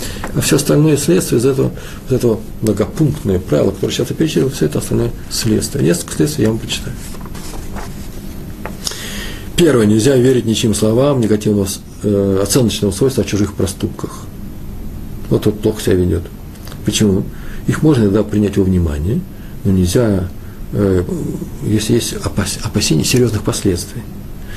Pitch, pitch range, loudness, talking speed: 105 Hz, 100-120 Hz, -15 LUFS, 135 wpm